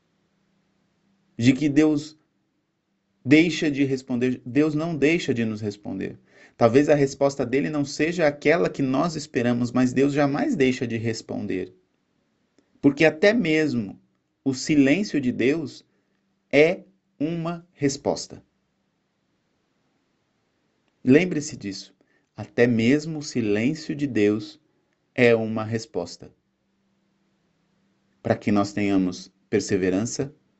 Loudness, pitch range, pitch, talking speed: -23 LUFS, 115-155 Hz, 140 Hz, 105 wpm